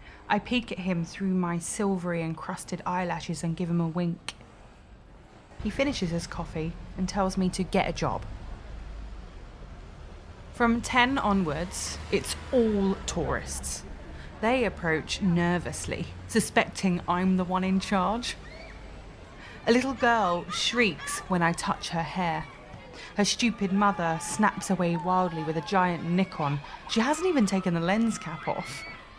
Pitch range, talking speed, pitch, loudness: 170-205 Hz, 140 wpm, 185 Hz, -28 LUFS